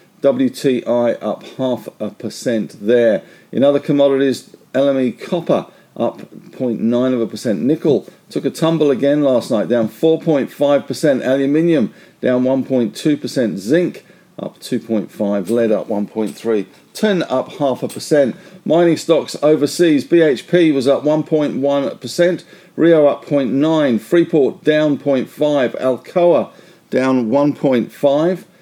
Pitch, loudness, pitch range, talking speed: 140 Hz, -16 LUFS, 125-160 Hz, 120 wpm